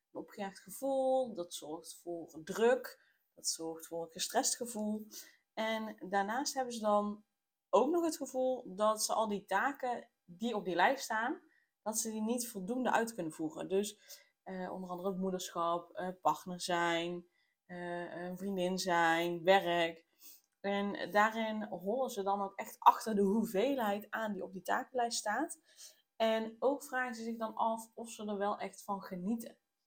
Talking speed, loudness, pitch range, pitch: 165 wpm, -36 LUFS, 180-235 Hz, 210 Hz